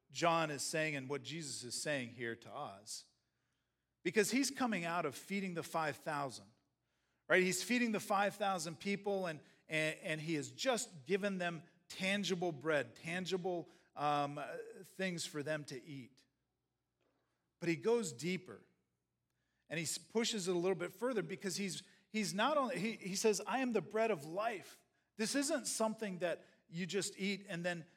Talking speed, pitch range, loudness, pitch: 165 wpm, 155-205 Hz, -39 LUFS, 180 Hz